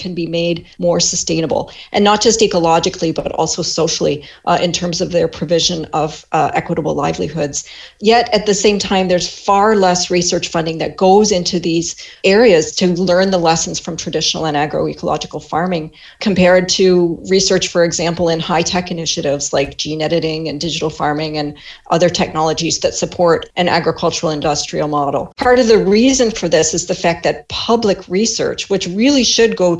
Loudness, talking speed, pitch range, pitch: -15 LUFS, 175 wpm, 160-185 Hz, 175 Hz